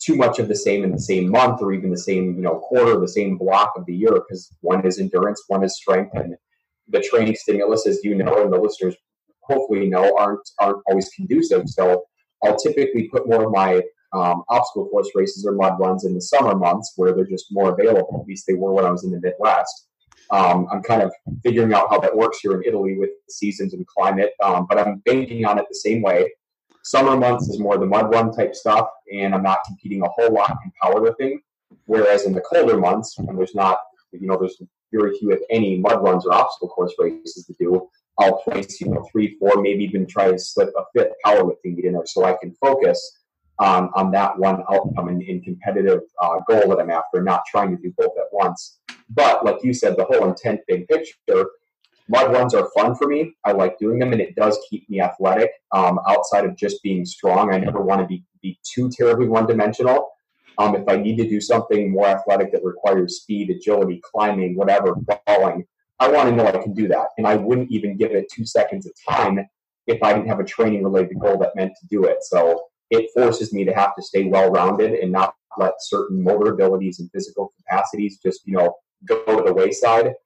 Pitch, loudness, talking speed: 105 Hz, -19 LUFS, 225 wpm